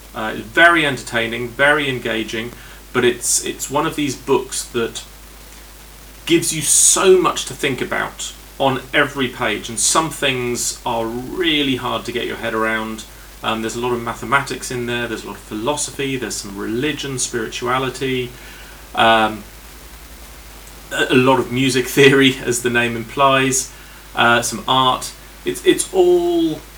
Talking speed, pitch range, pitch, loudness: 150 wpm, 115-140 Hz, 125 Hz, -17 LUFS